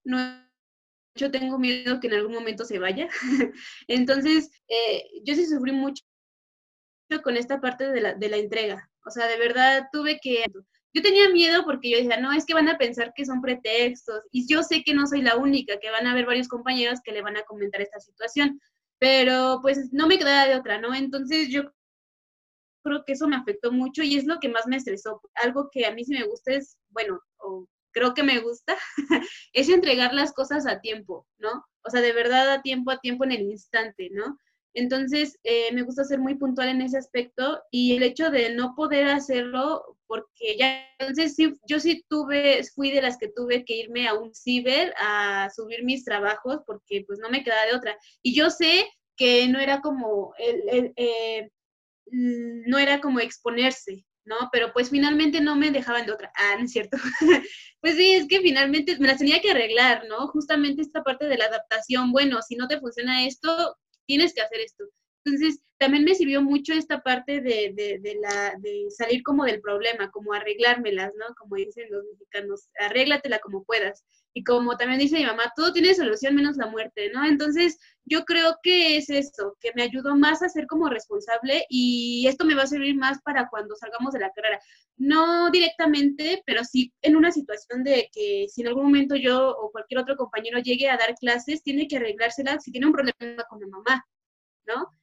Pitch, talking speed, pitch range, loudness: 260 Hz, 205 wpm, 230-290 Hz, -23 LUFS